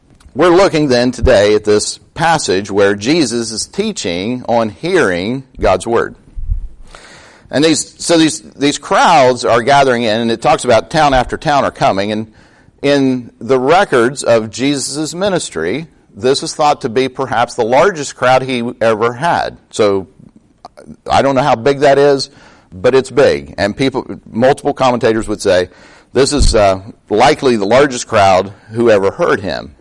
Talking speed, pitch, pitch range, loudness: 160 wpm, 125 Hz, 110-140 Hz, -13 LUFS